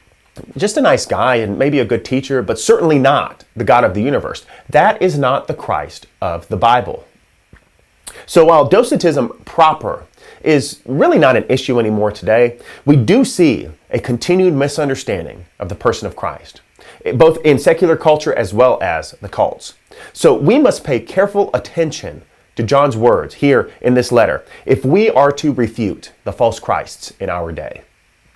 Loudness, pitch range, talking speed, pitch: -14 LUFS, 120-165 Hz, 170 wpm, 140 Hz